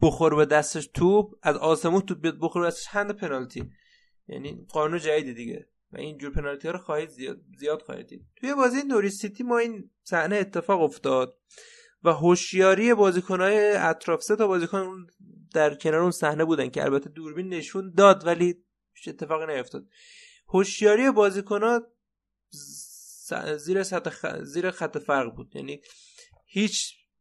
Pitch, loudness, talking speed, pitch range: 180 Hz, -25 LUFS, 150 wpm, 155-205 Hz